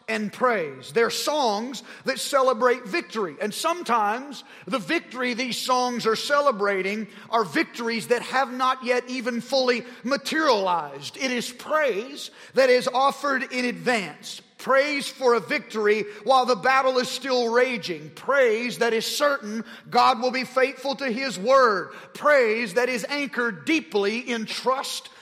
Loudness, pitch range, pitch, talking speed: -23 LUFS, 230-265 Hz, 250 Hz, 145 wpm